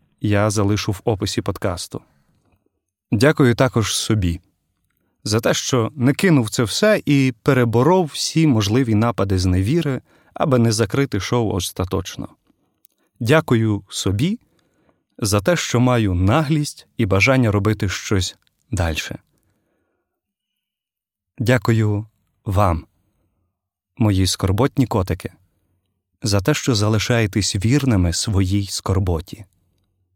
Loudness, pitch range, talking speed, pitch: -19 LUFS, 95-125 Hz, 100 wpm, 105 Hz